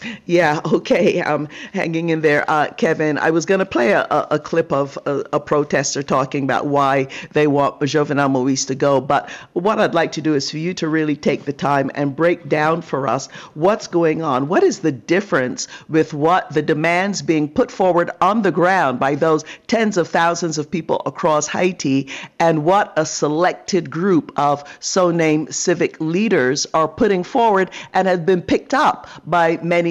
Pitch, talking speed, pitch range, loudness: 160 Hz, 190 wpm, 150-180 Hz, -18 LUFS